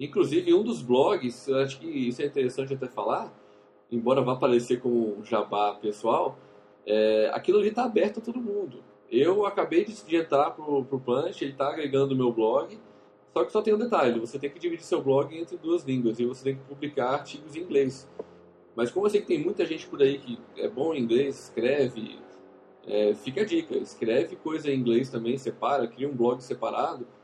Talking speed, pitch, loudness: 205 wpm, 140 Hz, -27 LUFS